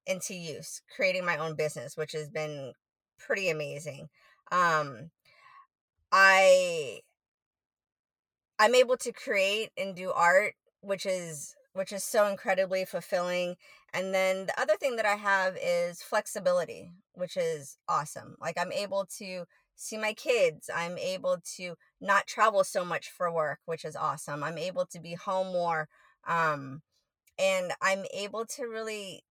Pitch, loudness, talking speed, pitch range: 190 Hz, -29 LUFS, 145 wpm, 170-225 Hz